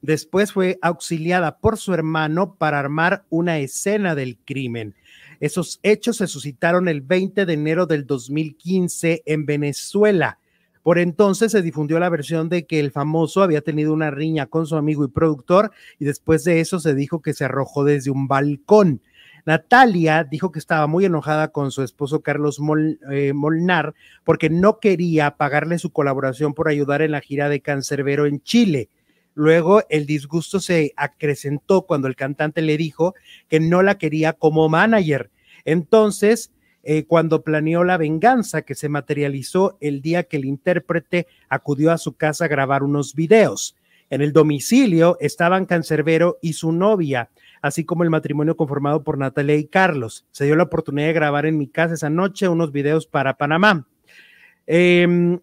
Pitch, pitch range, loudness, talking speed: 155 Hz, 145-175 Hz, -19 LUFS, 165 wpm